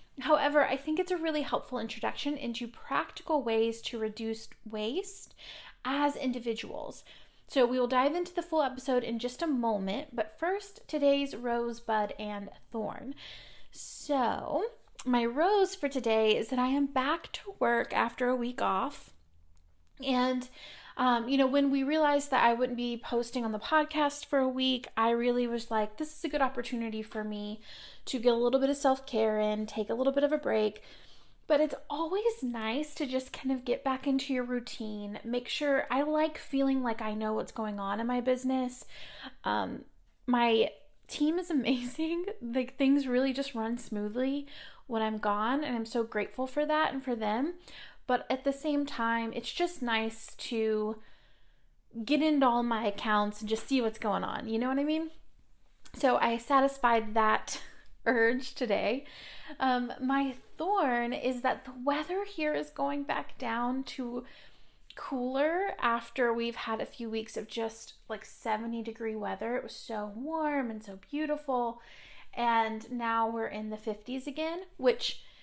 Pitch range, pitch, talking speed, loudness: 225-280 Hz, 250 Hz, 170 wpm, -31 LUFS